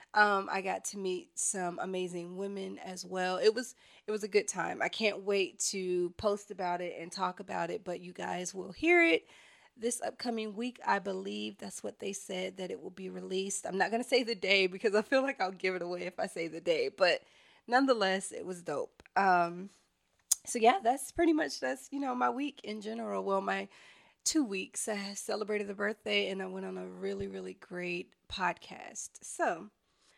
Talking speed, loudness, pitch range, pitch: 205 wpm, -33 LUFS, 180-220 Hz, 195 Hz